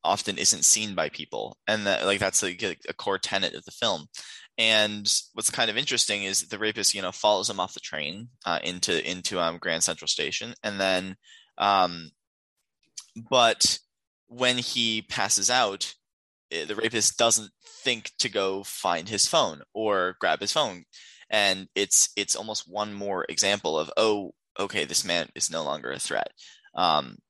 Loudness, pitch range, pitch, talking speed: -25 LUFS, 95-110 Hz, 105 Hz, 170 wpm